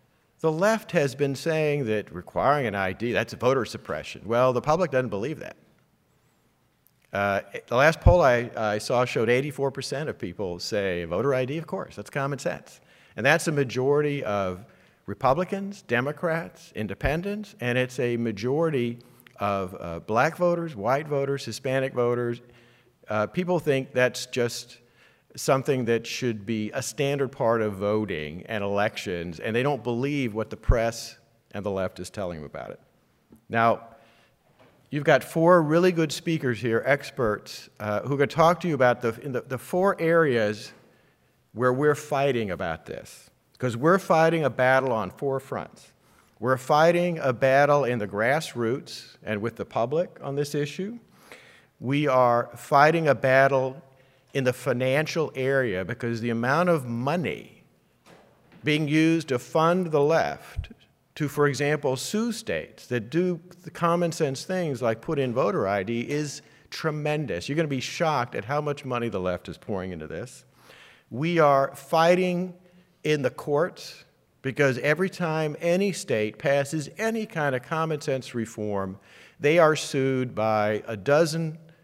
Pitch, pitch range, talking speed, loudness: 135 Hz, 115-155 Hz, 160 wpm, -25 LUFS